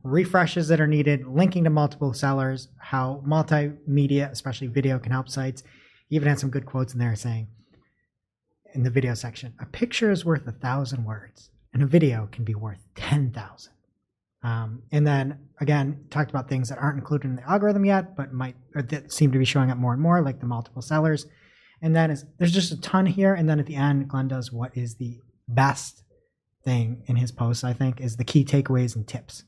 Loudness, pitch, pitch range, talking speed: -24 LUFS, 135 Hz, 125-150 Hz, 210 wpm